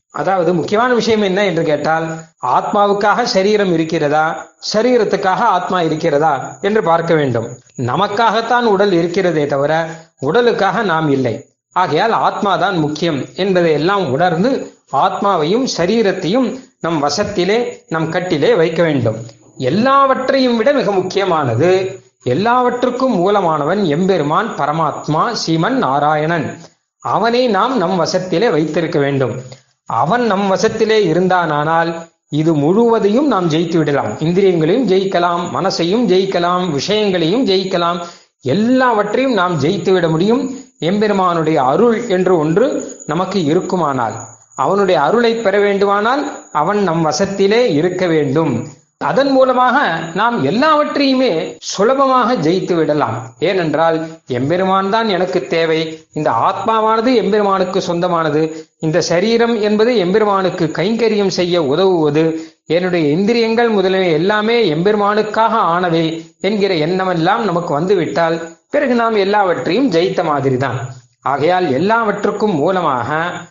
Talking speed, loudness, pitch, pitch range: 105 wpm, -14 LUFS, 180 Hz, 160-215 Hz